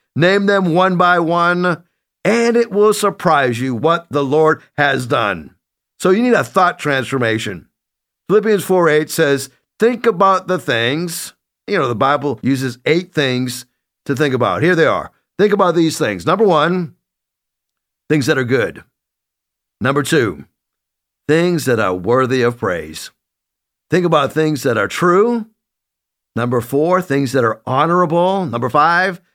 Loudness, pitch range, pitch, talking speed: -15 LUFS, 135-185 Hz, 165 Hz, 150 wpm